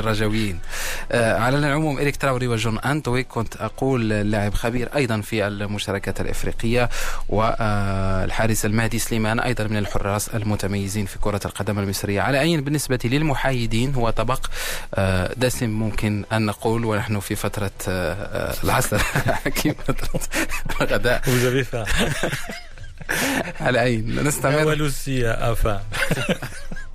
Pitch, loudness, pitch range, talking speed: 110 Hz, -23 LUFS, 105-125 Hz, 105 wpm